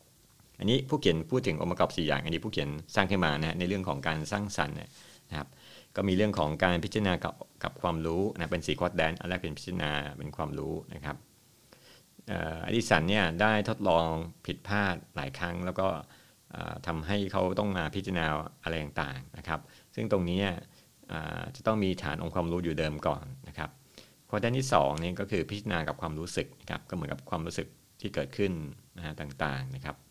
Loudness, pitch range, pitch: -32 LUFS, 80-100 Hz, 85 Hz